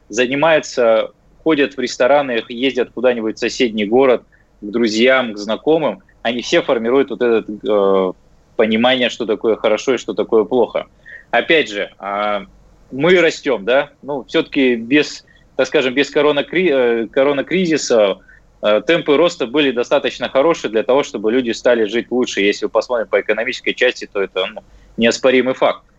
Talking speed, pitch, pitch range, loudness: 150 wpm, 125 Hz, 110-145 Hz, -16 LUFS